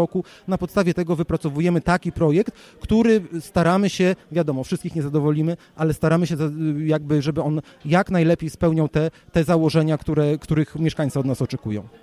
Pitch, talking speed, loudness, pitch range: 160 Hz, 155 wpm, -21 LUFS, 155-175 Hz